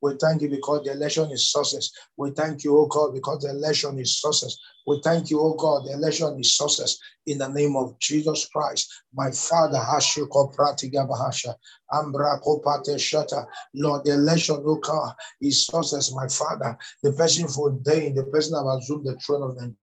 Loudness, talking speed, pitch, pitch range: -23 LUFS, 175 wpm, 145 Hz, 140-150 Hz